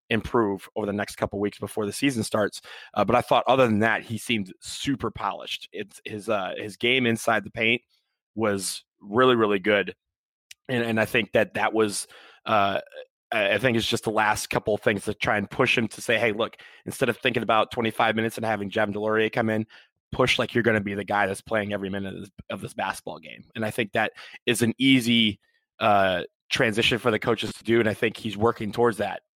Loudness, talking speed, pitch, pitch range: -24 LUFS, 225 wpm, 110 Hz, 105-120 Hz